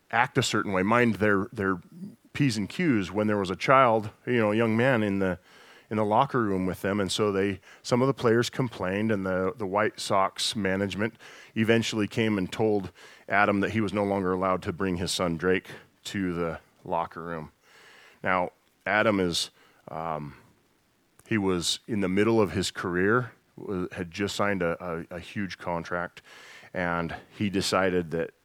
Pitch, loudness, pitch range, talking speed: 100 Hz, -27 LUFS, 90-110 Hz, 180 wpm